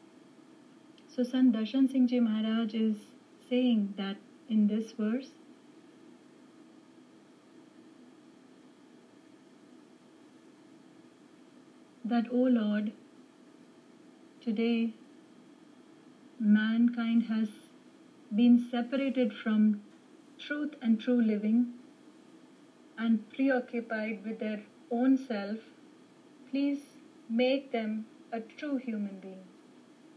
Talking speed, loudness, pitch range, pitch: 80 wpm, -31 LUFS, 230-300 Hz, 280 Hz